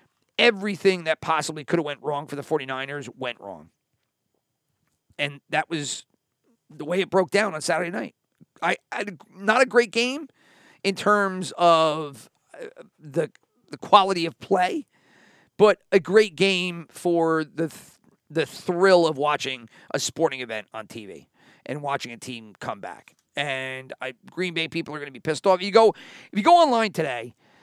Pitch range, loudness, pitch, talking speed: 145-200 Hz, -23 LUFS, 165 Hz, 165 wpm